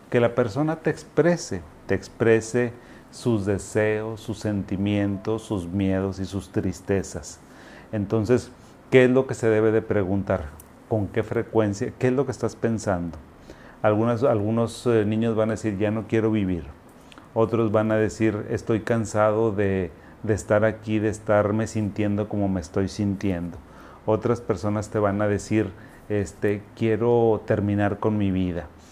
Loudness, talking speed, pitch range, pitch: -24 LUFS, 150 wpm, 100-115 Hz, 110 Hz